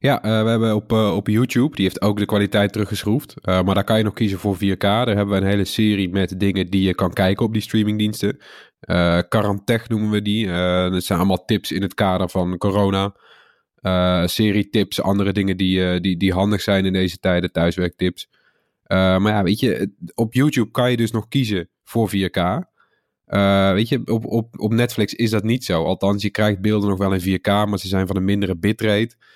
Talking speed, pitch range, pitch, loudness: 220 wpm, 95-110 Hz, 100 Hz, -19 LUFS